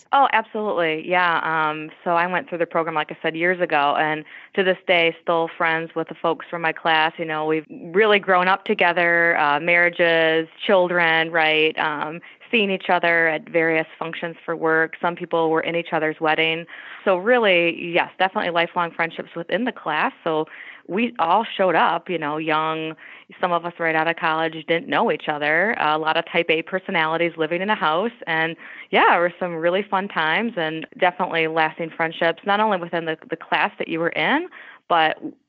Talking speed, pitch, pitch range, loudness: 195 wpm, 170 Hz, 160-180 Hz, -20 LUFS